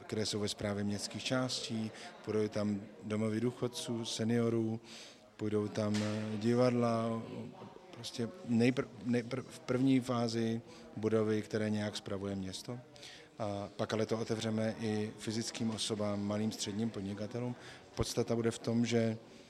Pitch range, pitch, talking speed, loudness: 105-120 Hz, 115 Hz, 125 wpm, -36 LUFS